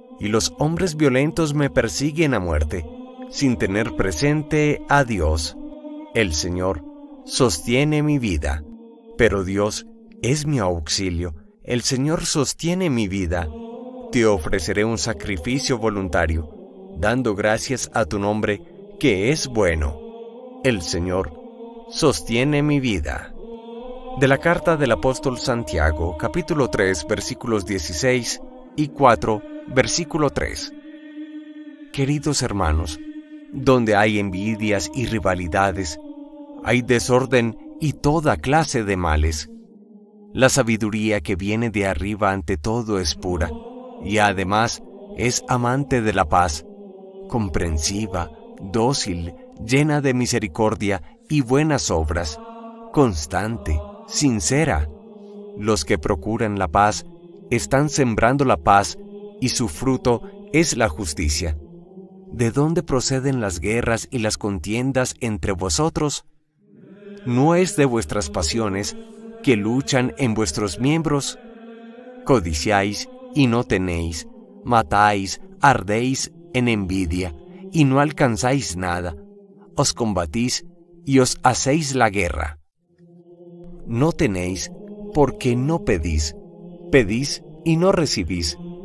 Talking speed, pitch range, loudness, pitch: 110 wpm, 105-175 Hz, -21 LUFS, 130 Hz